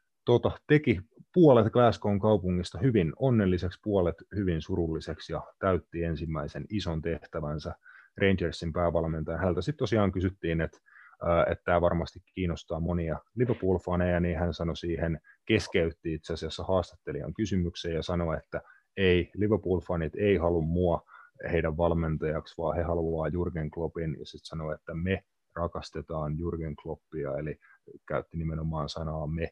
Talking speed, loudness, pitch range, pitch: 135 wpm, -30 LUFS, 80-95 Hz, 85 Hz